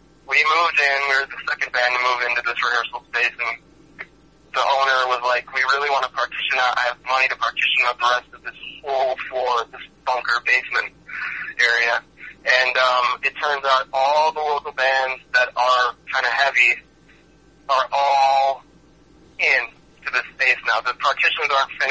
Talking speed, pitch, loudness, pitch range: 175 wpm, 130 Hz, -19 LUFS, 125-140 Hz